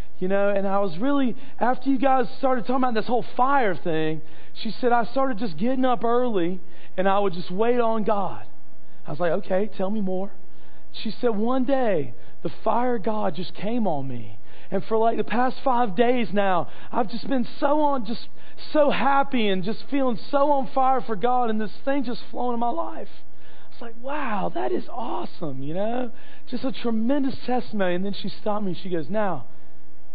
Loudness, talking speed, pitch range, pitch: -25 LUFS, 205 wpm, 190-250 Hz, 225 Hz